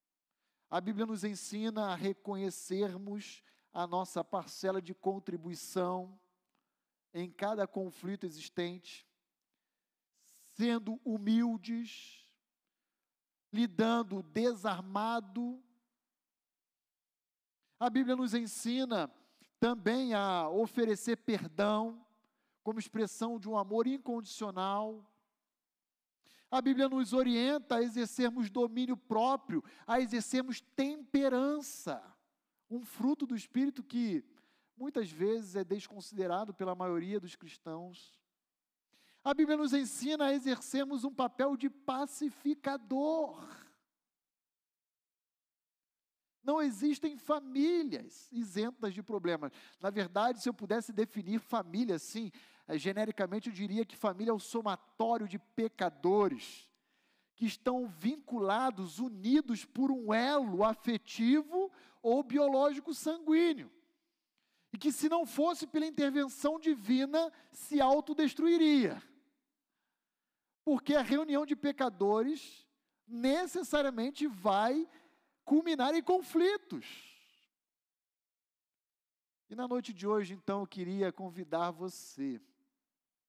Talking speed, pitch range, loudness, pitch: 95 wpm, 210-280 Hz, -35 LUFS, 240 Hz